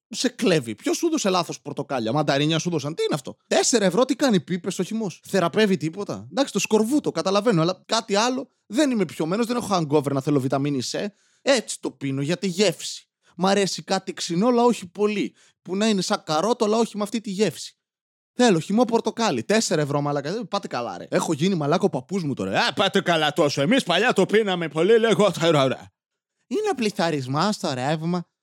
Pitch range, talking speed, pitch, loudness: 160-220 Hz, 200 wpm, 190 Hz, -23 LUFS